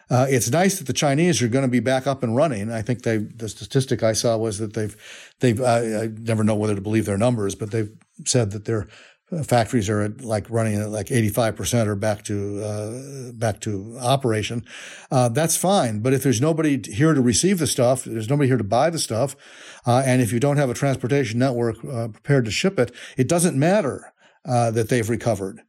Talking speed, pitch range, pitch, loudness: 220 wpm, 110-135 Hz, 120 Hz, -22 LUFS